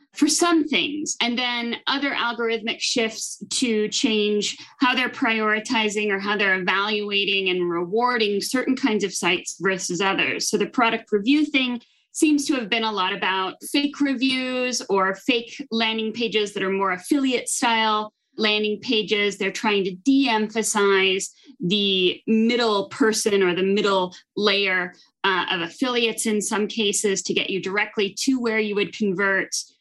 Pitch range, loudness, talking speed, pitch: 200-245 Hz, -22 LUFS, 155 wpm, 215 Hz